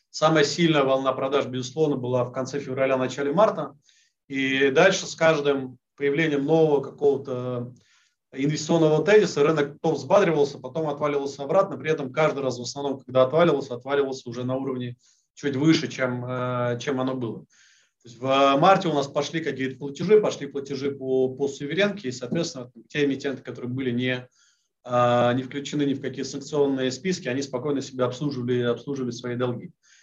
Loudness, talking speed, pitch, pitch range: -24 LUFS, 150 wpm, 140 Hz, 130-150 Hz